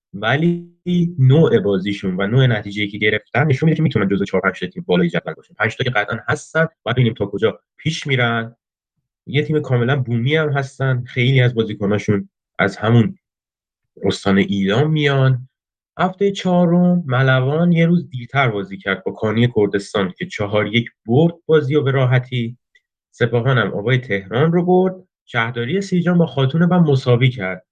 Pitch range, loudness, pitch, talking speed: 105-155 Hz, -18 LUFS, 130 Hz, 160 wpm